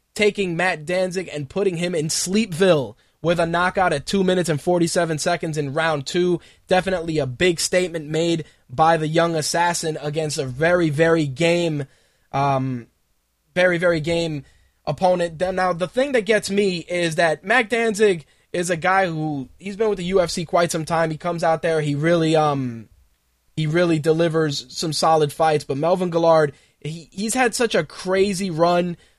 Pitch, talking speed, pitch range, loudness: 170 Hz, 170 wpm, 155-180 Hz, -20 LUFS